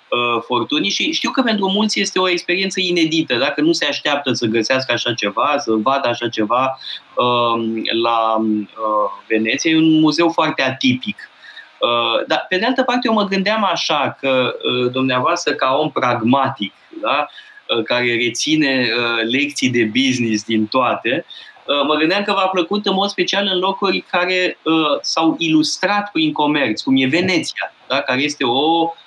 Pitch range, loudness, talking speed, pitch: 120-185 Hz, -17 LUFS, 150 wpm, 145 Hz